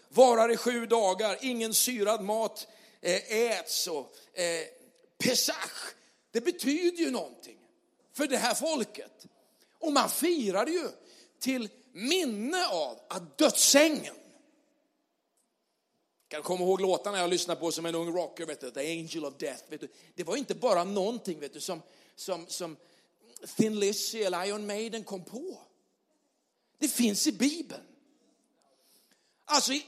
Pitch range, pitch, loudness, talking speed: 190-300 Hz, 230 Hz, -29 LUFS, 135 wpm